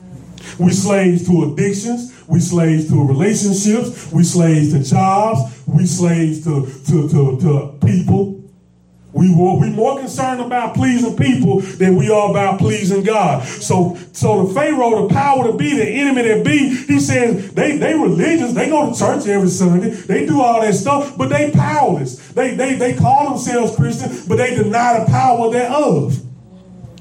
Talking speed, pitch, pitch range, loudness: 170 wpm, 190 Hz, 155-235 Hz, -15 LUFS